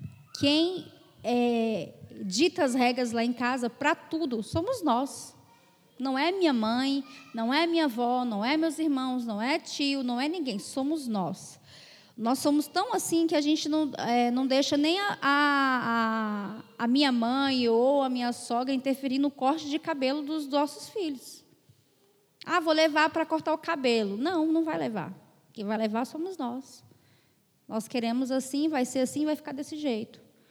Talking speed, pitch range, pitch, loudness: 170 wpm, 240-310 Hz, 270 Hz, -28 LUFS